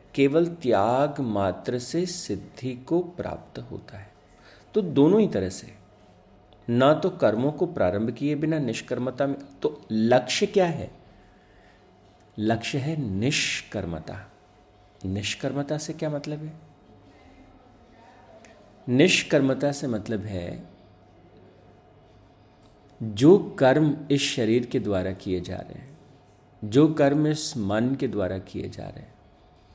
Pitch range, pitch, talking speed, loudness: 105-145 Hz, 120 Hz, 120 wpm, -25 LUFS